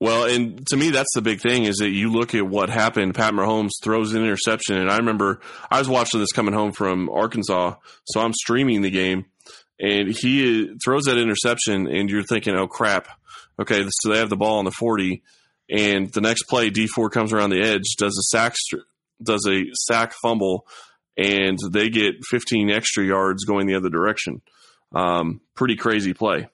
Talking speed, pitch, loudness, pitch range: 190 wpm, 105 Hz, -21 LUFS, 95-115 Hz